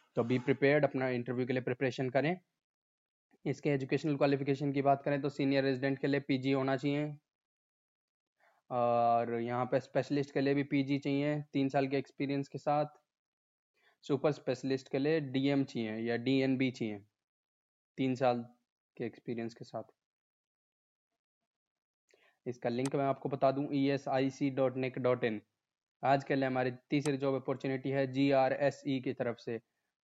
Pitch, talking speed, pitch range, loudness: 135 Hz, 130 wpm, 130-140 Hz, -33 LUFS